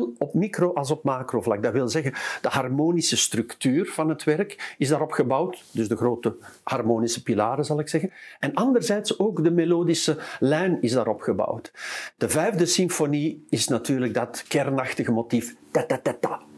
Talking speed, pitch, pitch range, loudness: 160 wpm, 150 Hz, 120-170 Hz, -24 LUFS